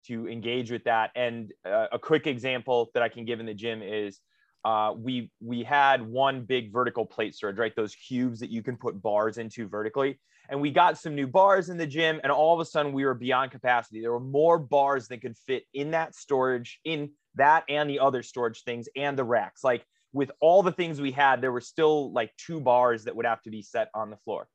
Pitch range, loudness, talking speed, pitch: 115-145 Hz, -27 LUFS, 235 wpm, 130 Hz